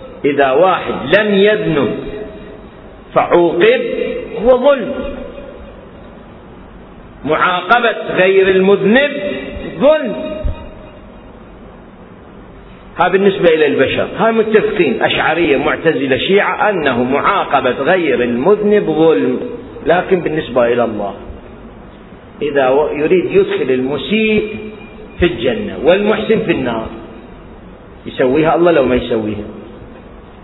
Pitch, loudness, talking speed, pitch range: 210 Hz, -13 LUFS, 85 wpm, 160-270 Hz